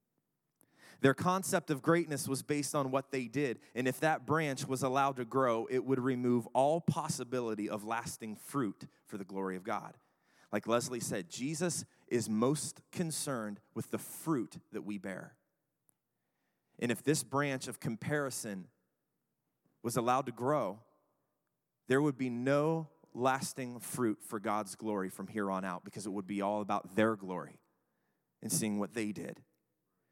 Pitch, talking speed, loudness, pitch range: 125 Hz, 160 wpm, -35 LUFS, 105-145 Hz